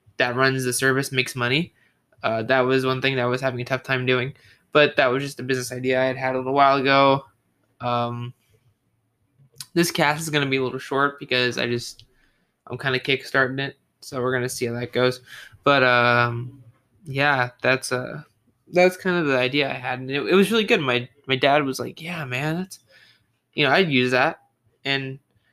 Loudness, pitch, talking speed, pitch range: -22 LUFS, 130 Hz, 215 wpm, 125-140 Hz